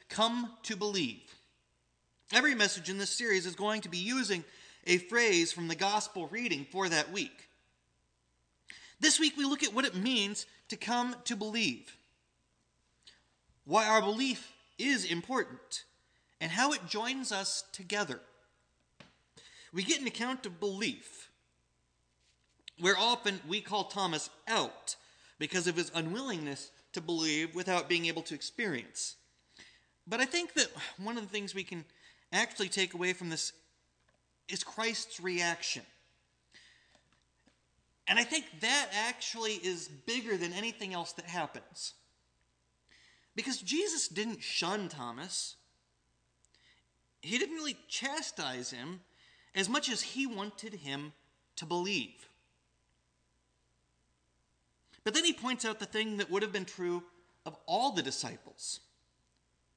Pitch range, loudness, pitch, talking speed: 155-225 Hz, -33 LUFS, 195 Hz, 135 wpm